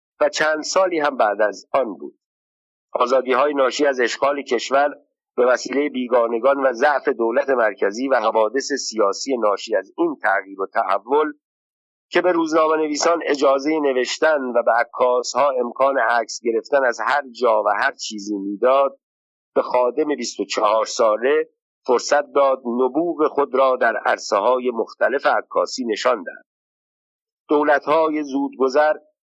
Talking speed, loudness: 140 wpm, -19 LUFS